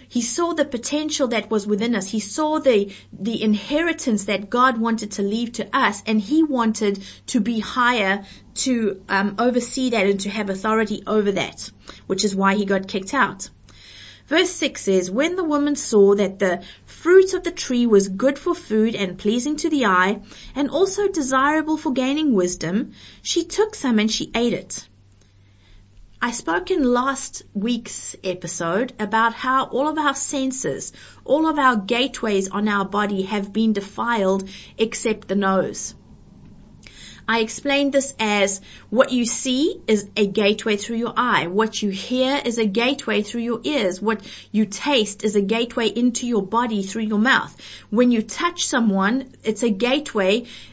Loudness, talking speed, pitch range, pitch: -21 LUFS, 170 wpm, 205-265 Hz, 225 Hz